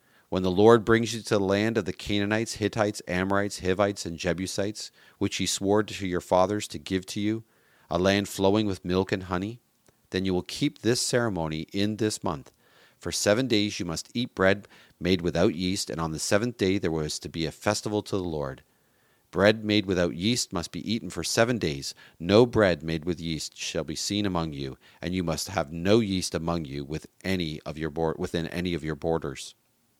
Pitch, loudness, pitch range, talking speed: 95 Hz, -27 LUFS, 85-105 Hz, 205 wpm